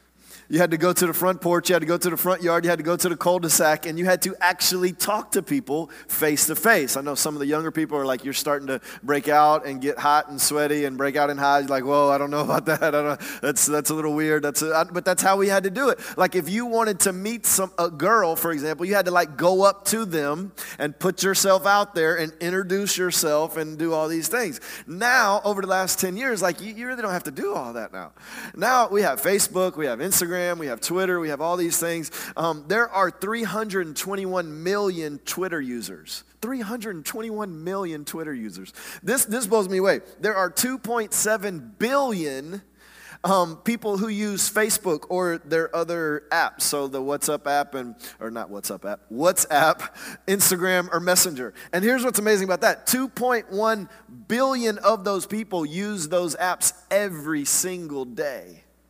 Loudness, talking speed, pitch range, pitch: -22 LUFS, 210 wpm, 155-200 Hz, 180 Hz